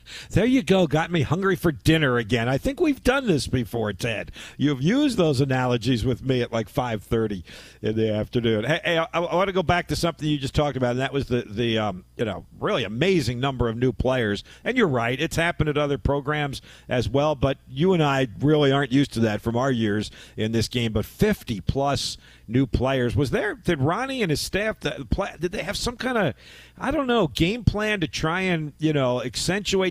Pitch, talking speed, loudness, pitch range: 140 Hz, 220 wpm, -24 LUFS, 120-165 Hz